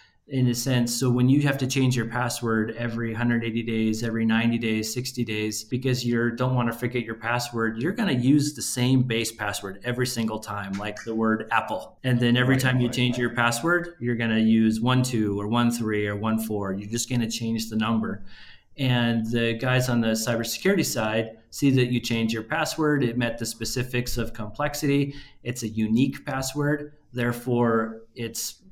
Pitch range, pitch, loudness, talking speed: 110-125 Hz, 120 Hz, -25 LUFS, 195 wpm